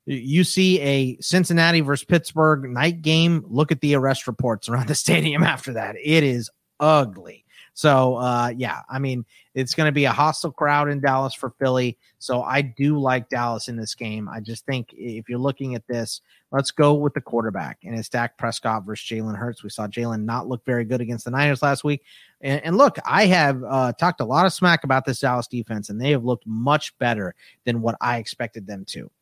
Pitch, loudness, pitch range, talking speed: 130 Hz, -21 LUFS, 120-150 Hz, 215 wpm